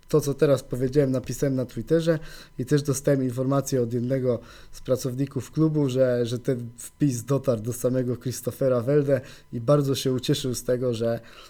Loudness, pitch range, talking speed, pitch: -25 LUFS, 125-140 Hz, 165 wpm, 130 Hz